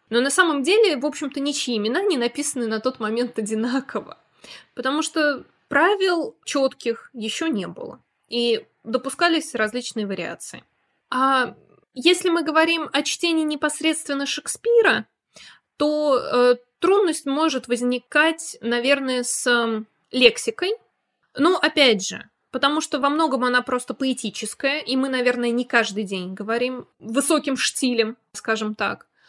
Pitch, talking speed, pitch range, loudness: 265 Hz, 125 wpm, 240-305 Hz, -21 LUFS